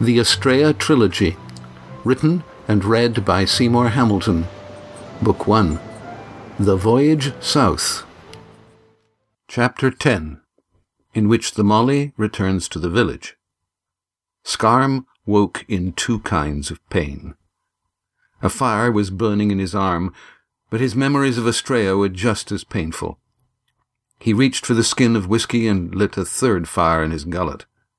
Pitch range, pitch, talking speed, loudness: 95-120 Hz, 110 Hz, 135 wpm, -18 LUFS